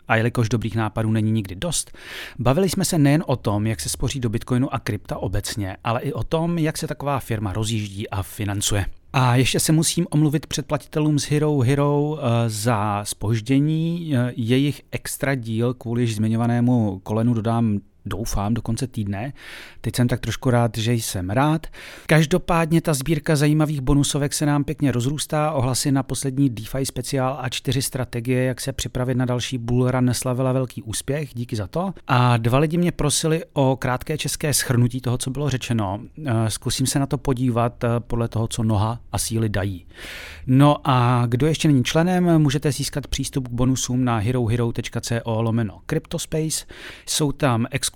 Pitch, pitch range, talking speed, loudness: 125 Hz, 115-145 Hz, 170 wpm, -22 LUFS